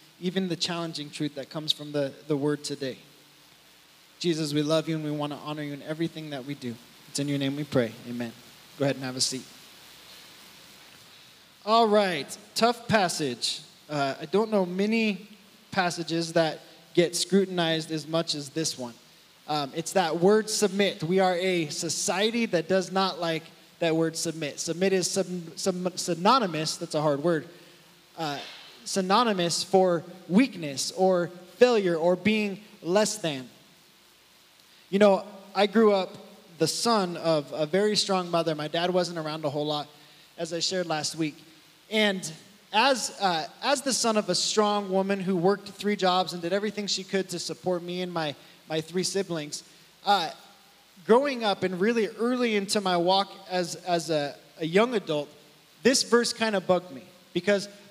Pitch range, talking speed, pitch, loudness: 155-200 Hz, 170 wpm, 175 Hz, -27 LUFS